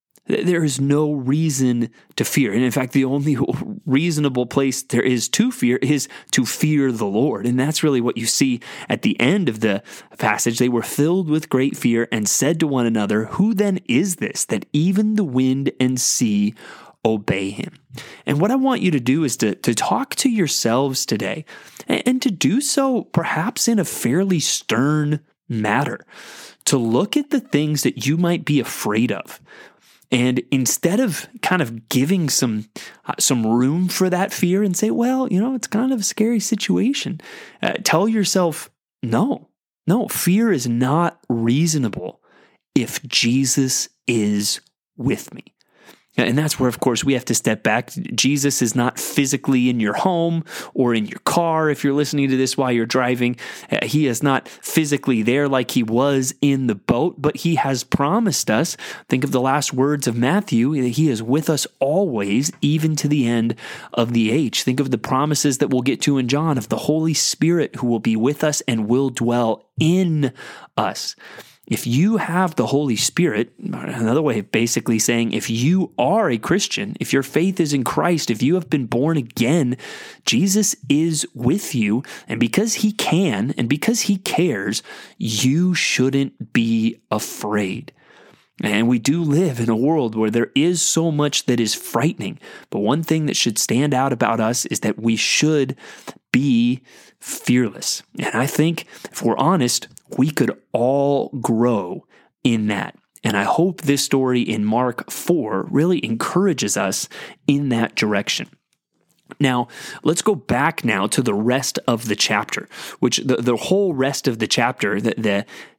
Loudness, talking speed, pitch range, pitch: -19 LUFS, 175 wpm, 120-165 Hz, 135 Hz